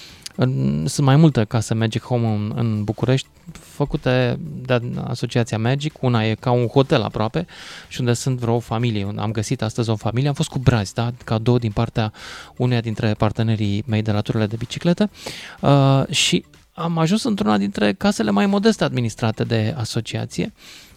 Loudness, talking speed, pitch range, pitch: -20 LUFS, 165 wpm, 110-140 Hz, 120 Hz